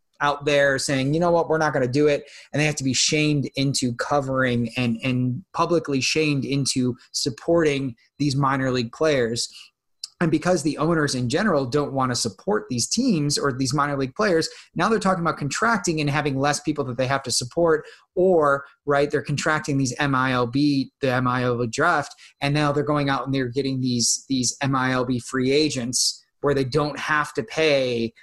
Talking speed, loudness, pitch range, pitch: 190 wpm, -22 LUFS, 130-150 Hz, 140 Hz